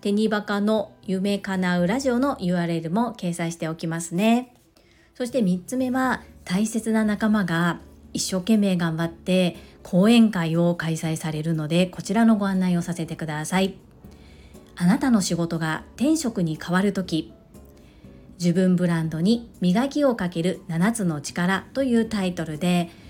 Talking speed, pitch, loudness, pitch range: 280 characters per minute, 180 Hz, -23 LUFS, 165-215 Hz